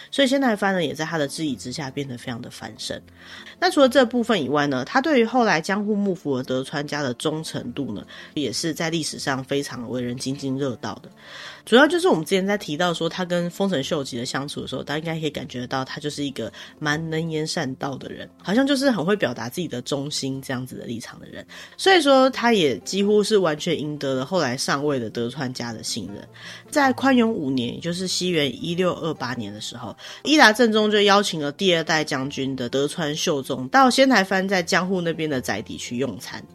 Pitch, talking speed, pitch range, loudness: 155 Hz, 335 characters per minute, 135-195 Hz, -22 LUFS